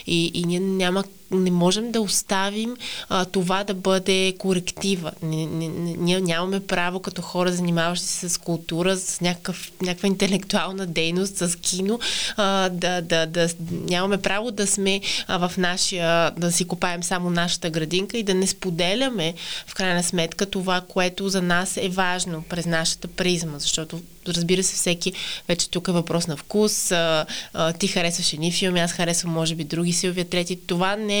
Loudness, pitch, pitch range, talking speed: -23 LUFS, 180 Hz, 170-190 Hz, 170 wpm